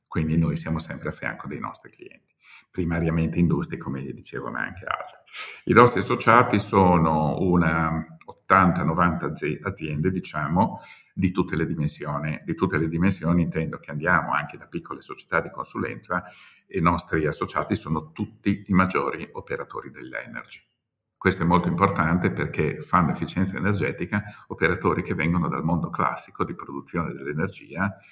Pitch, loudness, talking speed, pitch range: 85 Hz, -24 LUFS, 145 wpm, 80-95 Hz